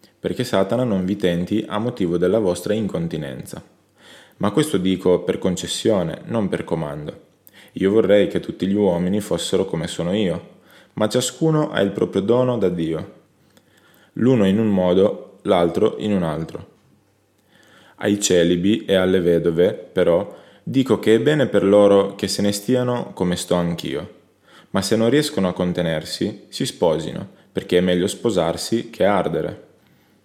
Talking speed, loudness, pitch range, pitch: 155 wpm, -20 LUFS, 90-110 Hz, 100 Hz